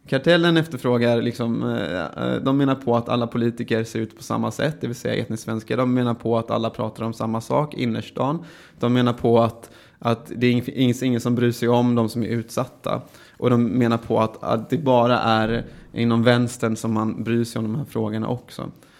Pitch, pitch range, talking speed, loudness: 120 Hz, 115-125 Hz, 205 wpm, -22 LUFS